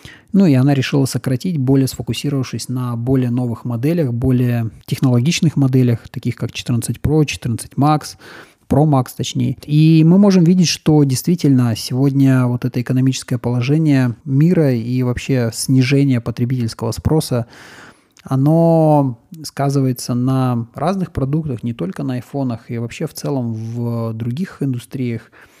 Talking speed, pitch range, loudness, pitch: 130 wpm, 120-145 Hz, -16 LUFS, 130 Hz